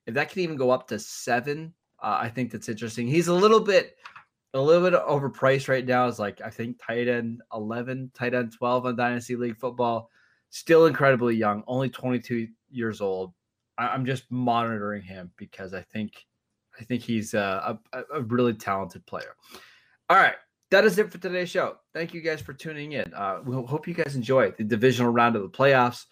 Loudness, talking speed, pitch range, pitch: -25 LUFS, 200 wpm, 115-140 Hz, 125 Hz